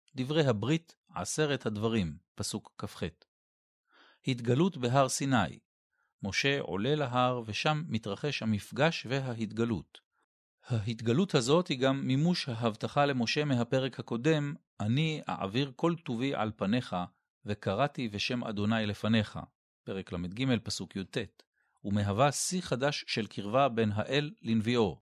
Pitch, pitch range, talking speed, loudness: 120 Hz, 105-145 Hz, 110 wpm, -31 LUFS